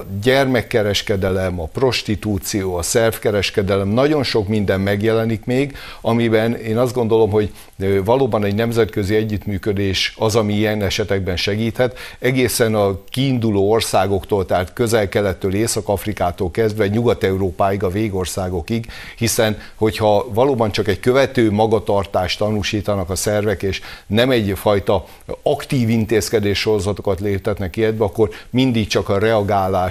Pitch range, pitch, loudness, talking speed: 100-115 Hz, 105 Hz, -18 LUFS, 120 wpm